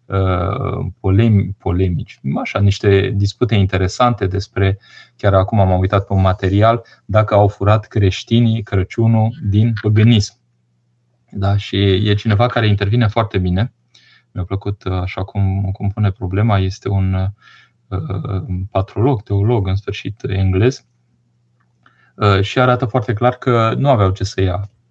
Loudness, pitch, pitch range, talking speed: -16 LUFS, 100 Hz, 95-110 Hz, 125 wpm